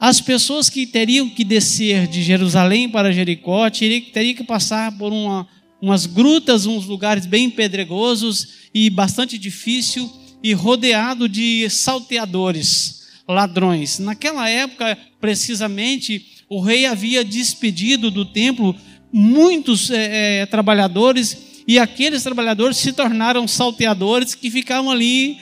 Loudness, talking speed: -16 LUFS, 120 wpm